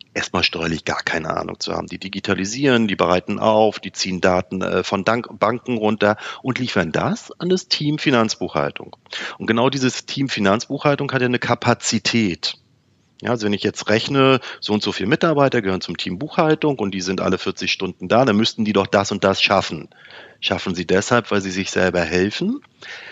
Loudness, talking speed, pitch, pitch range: -19 LUFS, 185 wpm, 110 Hz, 95-130 Hz